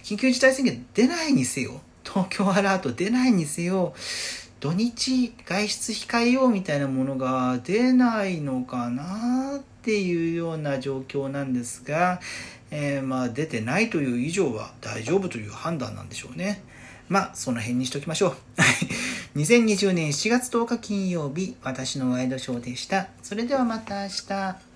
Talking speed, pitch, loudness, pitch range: 305 characters per minute, 175 Hz, -25 LUFS, 130-215 Hz